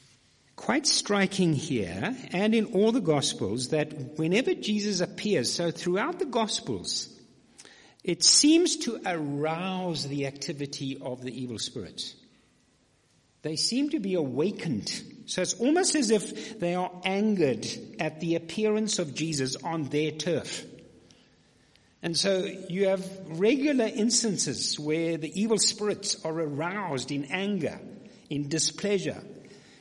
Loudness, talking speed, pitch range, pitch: -27 LUFS, 125 wpm, 155-215 Hz, 180 Hz